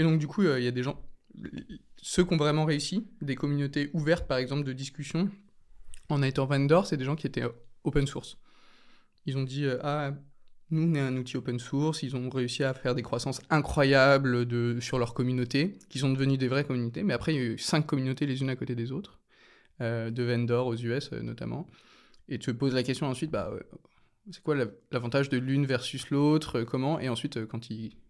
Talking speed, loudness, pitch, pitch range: 225 wpm, -29 LUFS, 135 Hz, 125-145 Hz